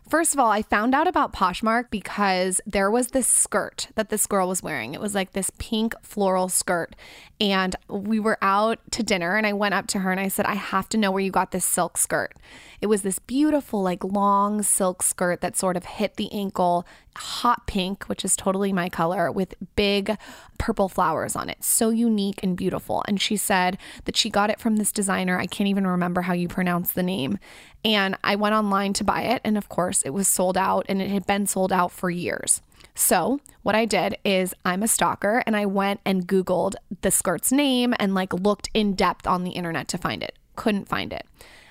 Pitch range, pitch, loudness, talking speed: 185-215 Hz, 200 Hz, -23 LUFS, 220 wpm